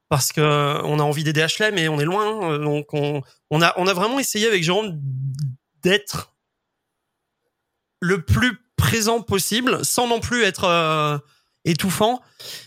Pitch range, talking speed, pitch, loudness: 150-215 Hz, 145 wpm, 170 Hz, -20 LUFS